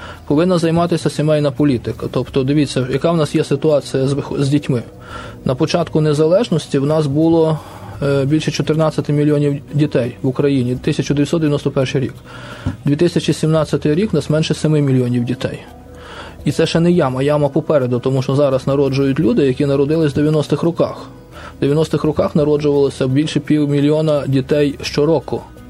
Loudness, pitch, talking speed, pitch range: -16 LUFS, 145 Hz, 145 wpm, 135-155 Hz